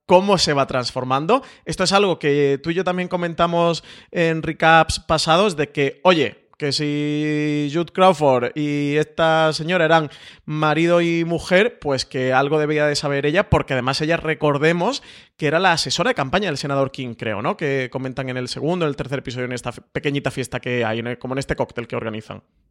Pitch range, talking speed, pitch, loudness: 135-170 Hz, 195 wpm, 150 Hz, -20 LUFS